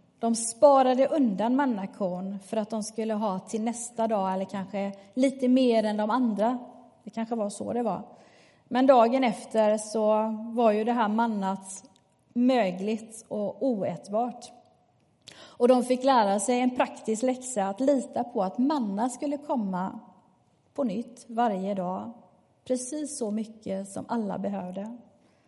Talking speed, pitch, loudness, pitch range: 145 wpm, 225 Hz, -27 LUFS, 205-250 Hz